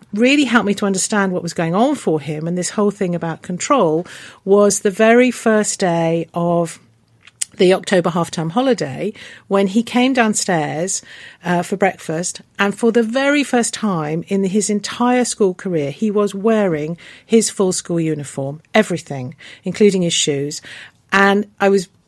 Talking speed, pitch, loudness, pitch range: 165 wpm, 195 Hz, -17 LUFS, 165-215 Hz